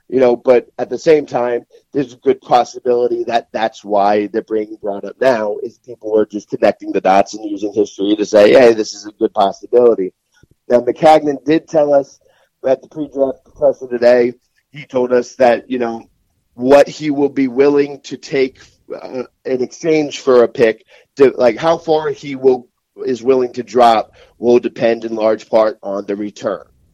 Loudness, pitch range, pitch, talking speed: -15 LUFS, 115-150 Hz, 125 Hz, 185 wpm